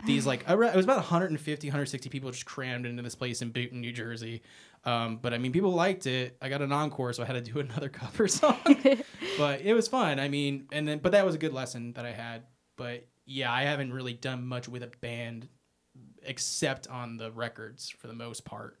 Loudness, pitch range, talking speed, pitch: -30 LUFS, 120-150 Hz, 230 wpm, 130 Hz